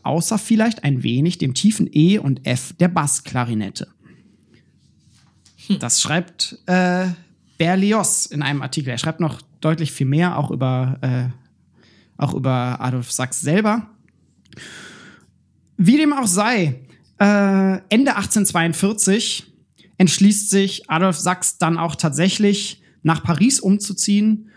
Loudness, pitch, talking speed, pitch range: -18 LUFS, 180 Hz, 120 wpm, 145-205 Hz